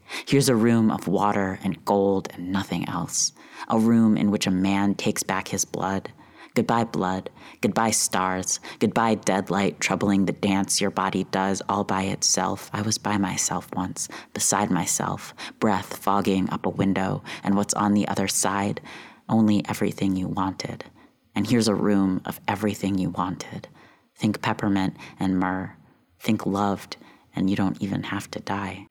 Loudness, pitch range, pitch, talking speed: -24 LUFS, 95-105 Hz, 100 Hz, 160 wpm